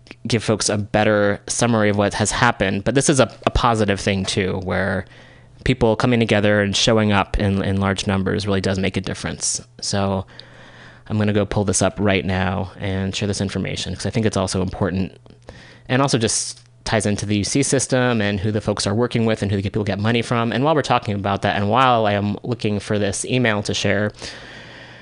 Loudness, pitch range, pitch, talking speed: -19 LUFS, 100-115 Hz, 105 Hz, 220 wpm